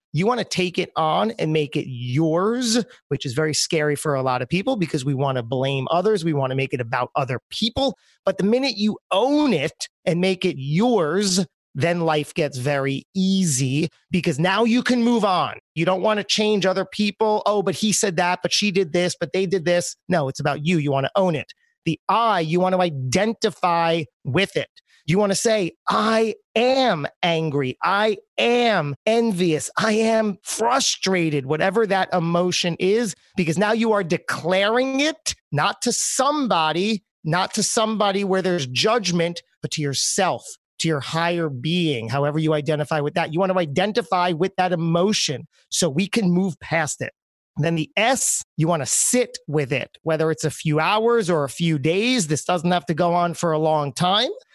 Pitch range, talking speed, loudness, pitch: 155-210 Hz, 195 wpm, -21 LUFS, 180 Hz